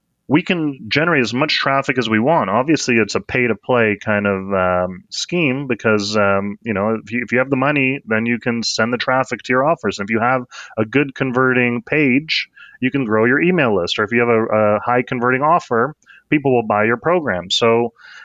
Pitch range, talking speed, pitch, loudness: 110-130 Hz, 225 wpm, 120 Hz, -17 LUFS